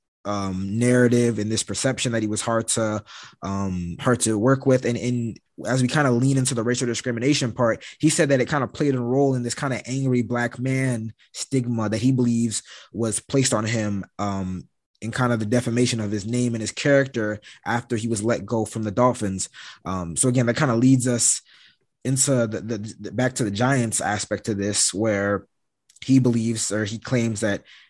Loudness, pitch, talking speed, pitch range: -23 LUFS, 120 Hz, 210 wpm, 110-125 Hz